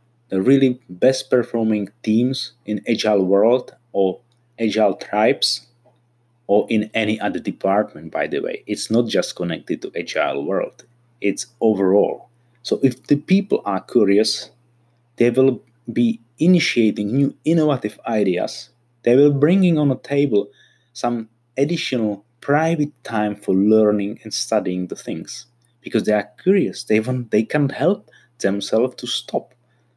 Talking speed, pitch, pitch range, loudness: 140 wpm, 120 Hz, 105-130 Hz, -20 LUFS